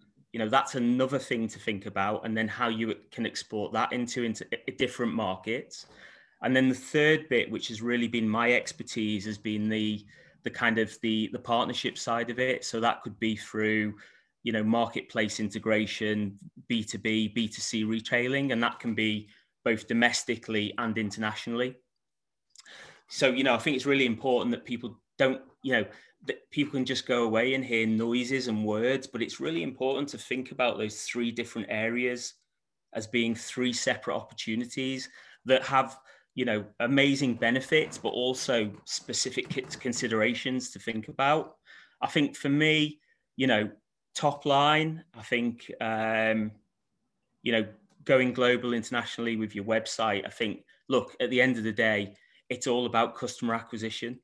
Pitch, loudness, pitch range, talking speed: 115 Hz, -29 LUFS, 110-125 Hz, 165 wpm